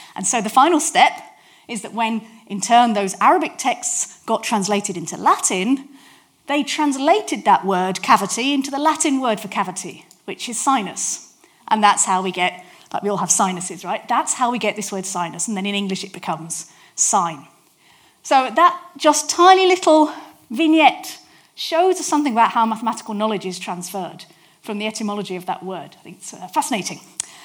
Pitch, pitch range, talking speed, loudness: 220 Hz, 190-290 Hz, 175 wpm, -18 LUFS